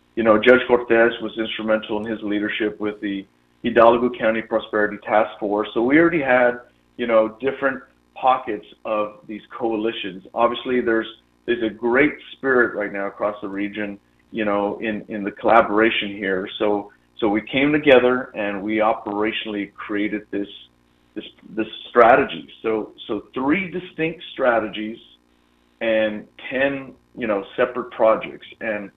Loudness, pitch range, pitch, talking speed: -21 LUFS, 100-115 Hz, 110 Hz, 145 wpm